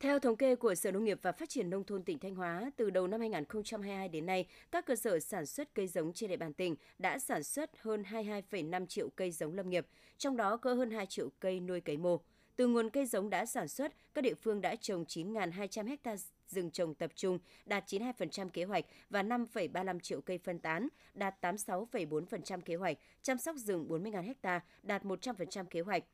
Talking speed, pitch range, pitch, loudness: 215 wpm, 180-230 Hz, 200 Hz, -38 LUFS